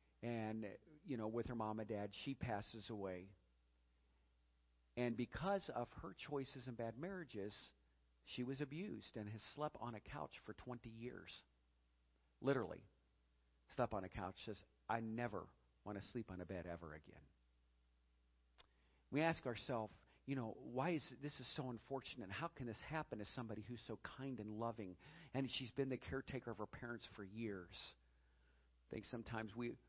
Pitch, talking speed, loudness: 110 Hz, 170 wpm, -48 LUFS